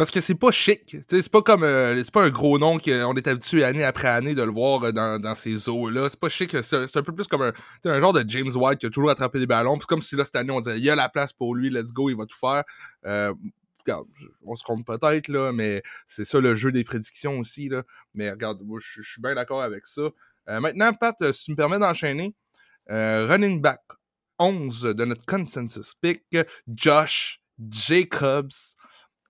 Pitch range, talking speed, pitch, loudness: 120-160 Hz, 225 wpm, 135 Hz, -23 LUFS